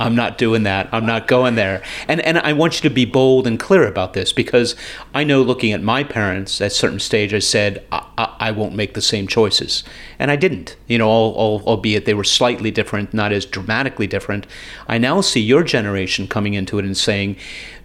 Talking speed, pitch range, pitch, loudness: 225 wpm, 100-125 Hz, 110 Hz, -17 LUFS